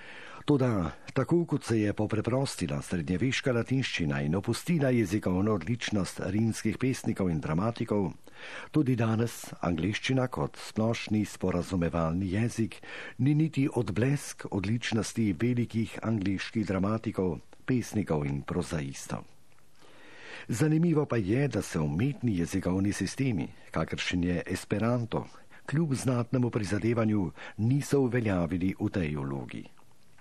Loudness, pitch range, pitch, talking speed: -30 LUFS, 95-125 Hz, 110 Hz, 105 wpm